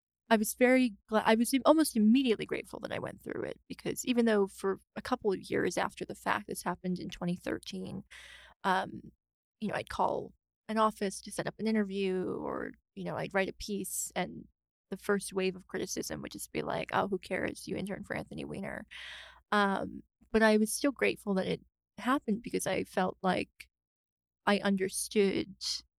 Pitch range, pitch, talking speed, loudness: 185-220 Hz, 205 Hz, 185 wpm, -32 LUFS